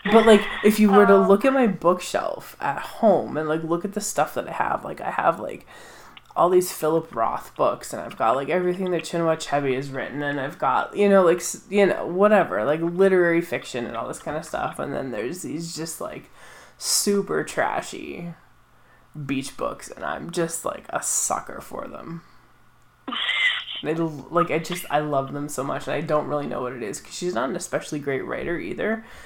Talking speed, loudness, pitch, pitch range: 205 wpm, -23 LUFS, 170 Hz, 150-195 Hz